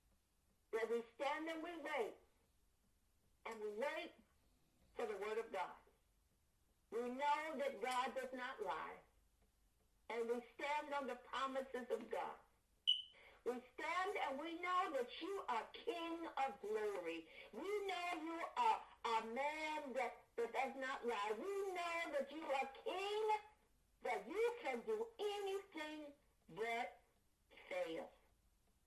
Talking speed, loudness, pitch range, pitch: 135 wpm, -45 LUFS, 250-395 Hz, 300 Hz